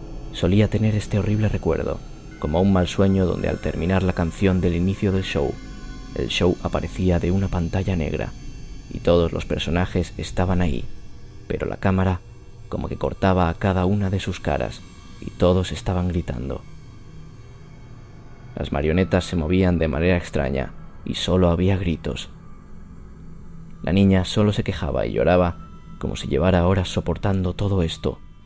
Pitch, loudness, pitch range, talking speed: 90 Hz, -22 LUFS, 85-100 Hz, 150 wpm